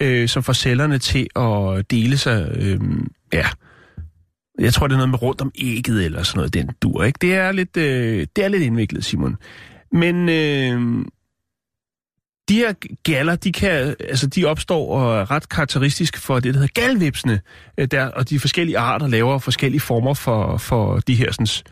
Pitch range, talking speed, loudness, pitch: 115-150 Hz, 180 wpm, -19 LUFS, 130 Hz